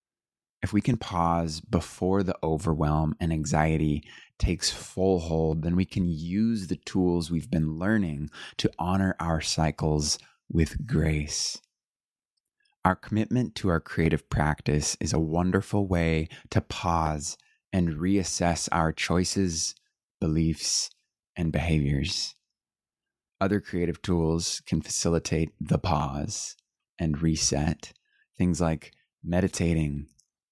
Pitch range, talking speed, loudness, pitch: 80-95 Hz, 115 wpm, -27 LUFS, 85 Hz